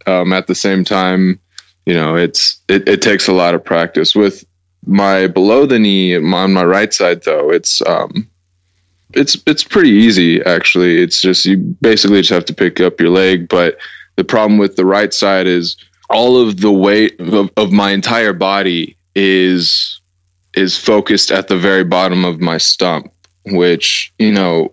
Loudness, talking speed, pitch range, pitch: -11 LUFS, 175 wpm, 90-100 Hz, 95 Hz